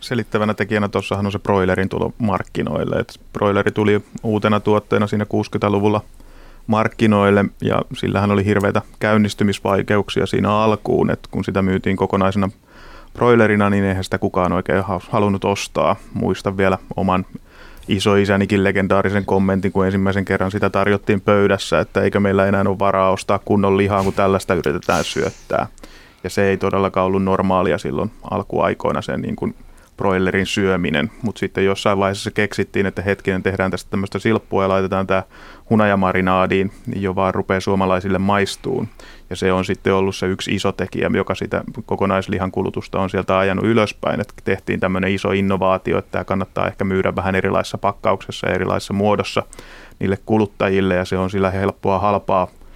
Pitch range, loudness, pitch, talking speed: 95-100 Hz, -18 LUFS, 100 Hz, 155 wpm